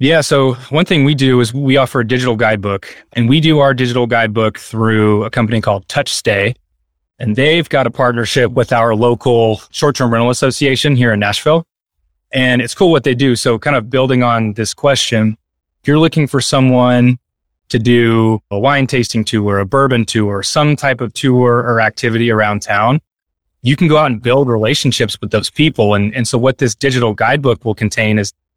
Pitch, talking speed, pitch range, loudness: 120 Hz, 195 wpm, 110-135 Hz, -13 LUFS